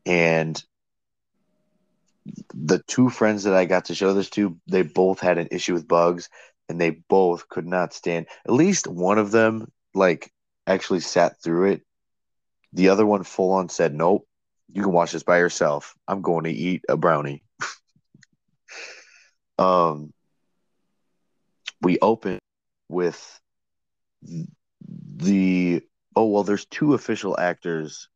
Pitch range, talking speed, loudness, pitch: 85-110 Hz, 135 wpm, -22 LUFS, 95 Hz